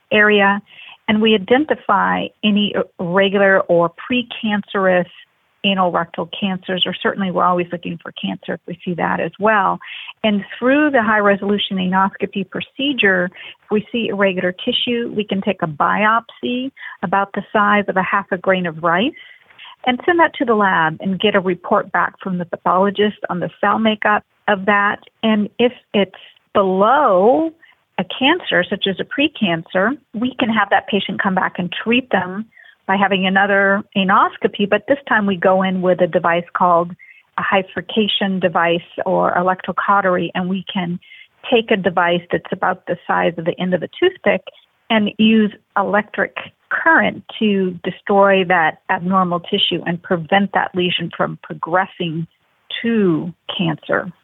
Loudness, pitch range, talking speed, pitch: -17 LUFS, 185-220 Hz, 160 wpm, 200 Hz